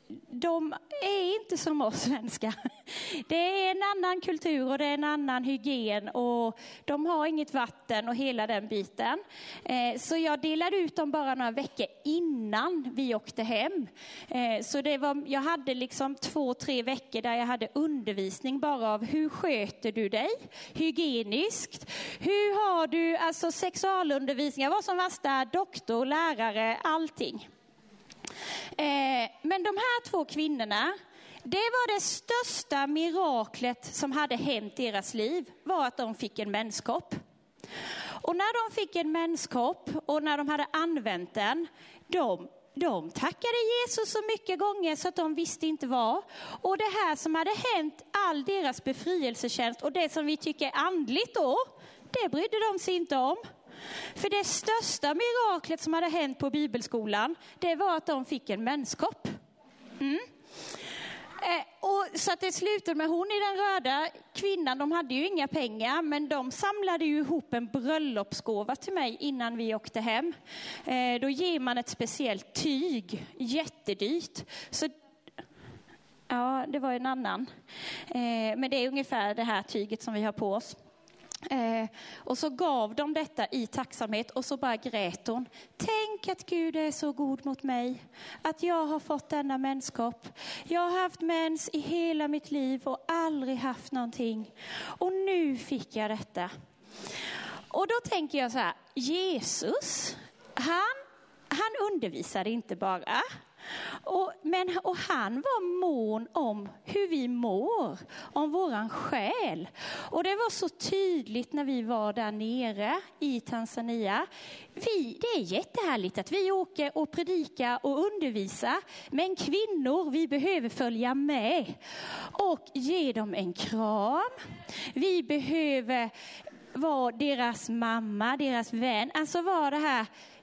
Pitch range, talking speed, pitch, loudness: 245-345 Hz, 150 wpm, 295 Hz, -31 LUFS